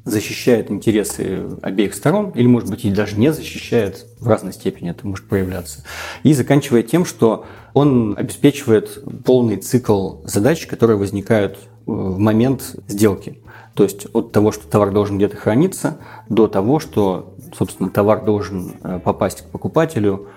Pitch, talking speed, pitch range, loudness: 110 Hz, 145 wpm, 100-125 Hz, -18 LUFS